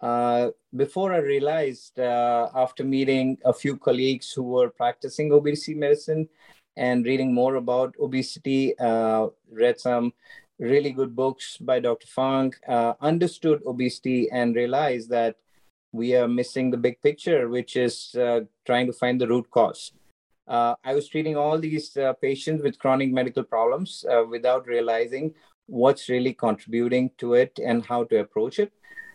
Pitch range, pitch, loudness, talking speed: 120-145 Hz, 130 Hz, -24 LUFS, 155 wpm